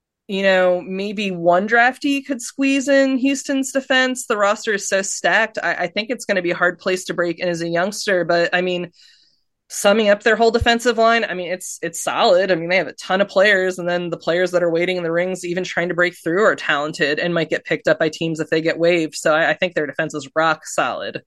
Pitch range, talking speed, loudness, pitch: 175-220 Hz, 255 wpm, -18 LUFS, 185 Hz